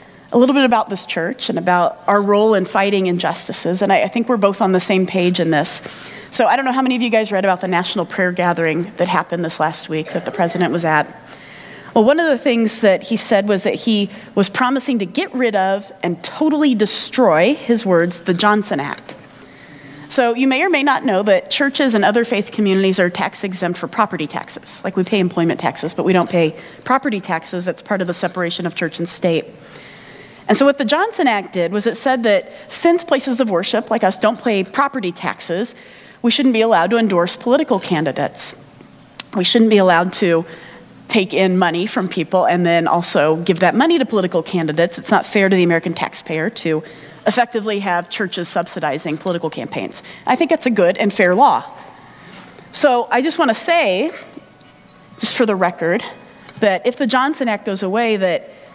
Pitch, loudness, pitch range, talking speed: 195 Hz, -17 LUFS, 175-240 Hz, 205 wpm